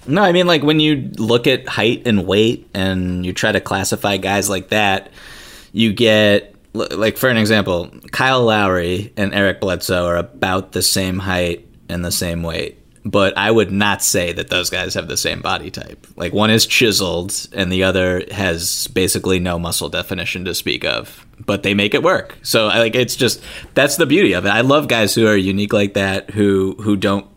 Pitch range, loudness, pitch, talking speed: 90-110 Hz, -16 LUFS, 100 Hz, 200 wpm